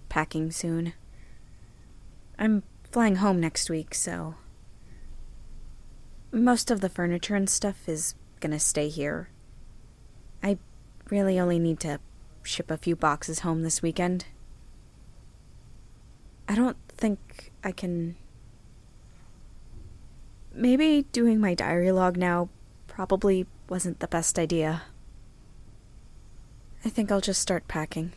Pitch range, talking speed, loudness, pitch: 150-195 Hz, 110 wpm, -27 LUFS, 170 Hz